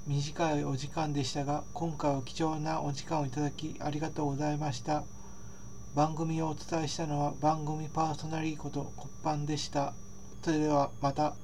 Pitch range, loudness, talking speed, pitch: 145-155 Hz, -33 LUFS, 350 characters per minute, 150 Hz